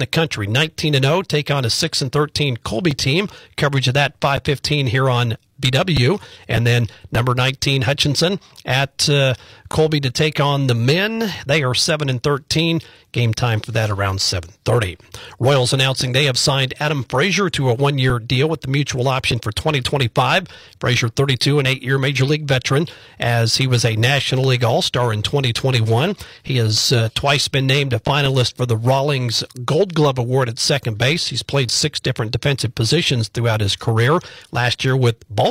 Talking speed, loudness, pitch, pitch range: 195 wpm, -18 LUFS, 130 Hz, 120-145 Hz